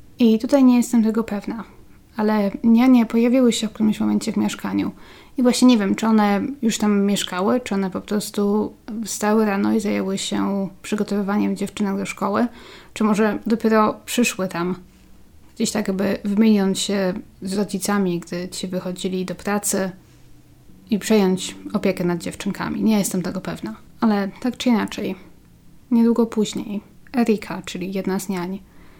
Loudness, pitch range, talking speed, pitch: -21 LUFS, 190-225 Hz, 155 wpm, 205 Hz